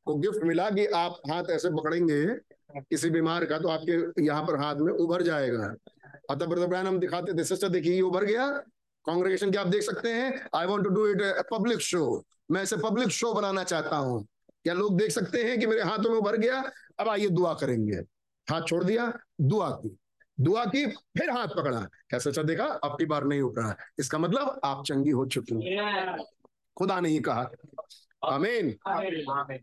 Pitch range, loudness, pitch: 150-205 Hz, -28 LUFS, 175 Hz